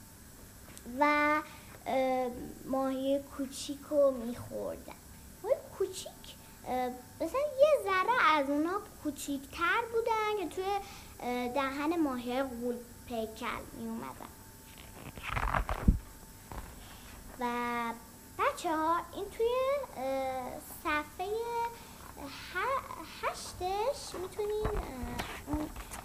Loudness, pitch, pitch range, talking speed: -34 LUFS, 295 Hz, 255-375 Hz, 65 wpm